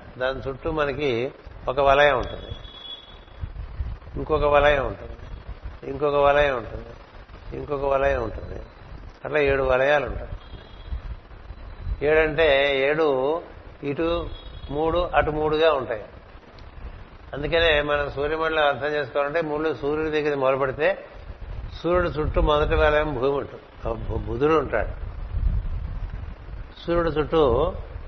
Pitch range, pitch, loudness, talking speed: 95-150 Hz, 135 Hz, -23 LUFS, 95 wpm